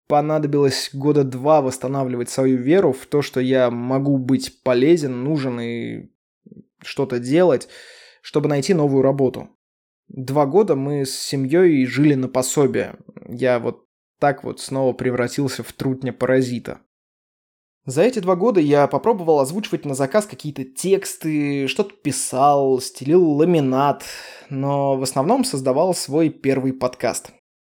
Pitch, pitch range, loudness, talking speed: 140 Hz, 130-155 Hz, -19 LUFS, 130 wpm